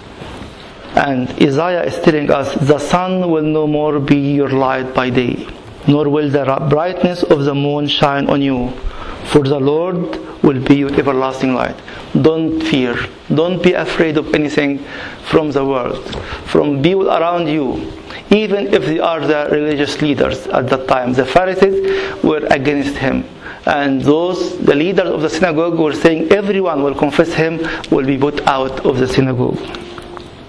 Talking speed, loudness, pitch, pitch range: 160 wpm, -15 LUFS, 150 Hz, 140-165 Hz